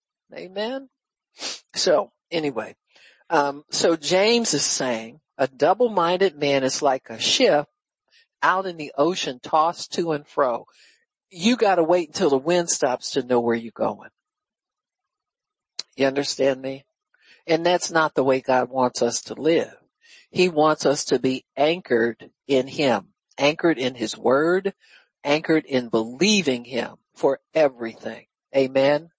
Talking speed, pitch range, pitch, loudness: 140 wpm, 130-175 Hz, 145 Hz, -22 LUFS